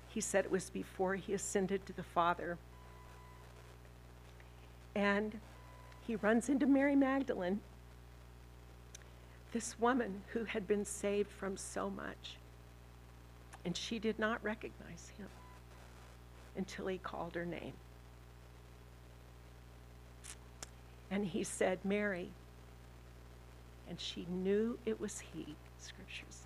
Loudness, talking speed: -38 LUFS, 105 wpm